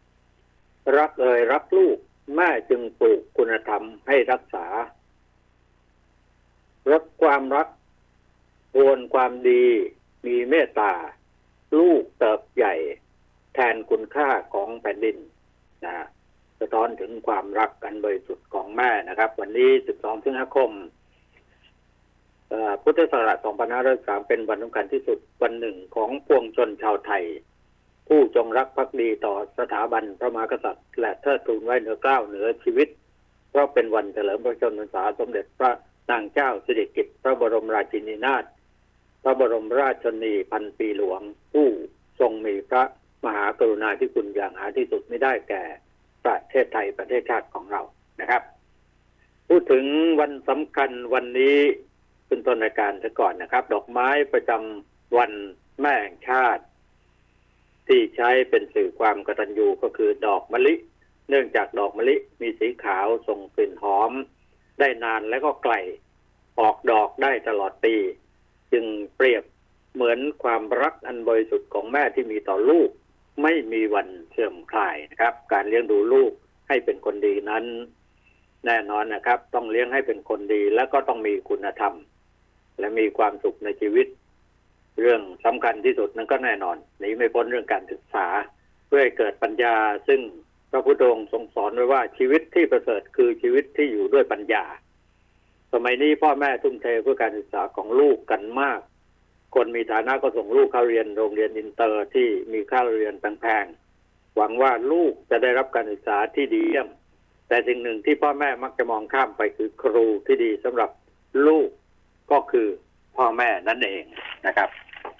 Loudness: -23 LUFS